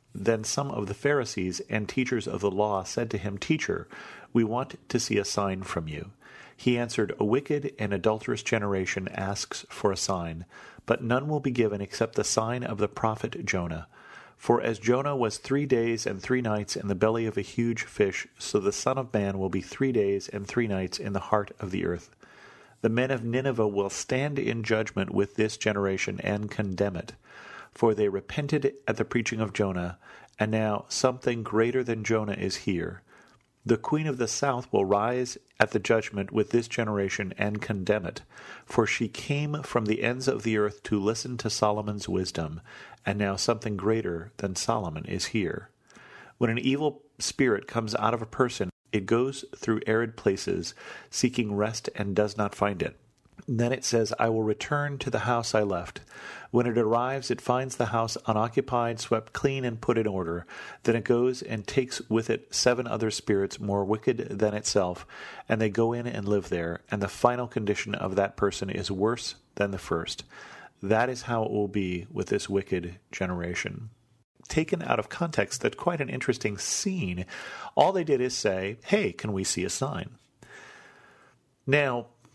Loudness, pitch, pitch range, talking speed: -28 LUFS, 110 Hz, 100-120 Hz, 185 wpm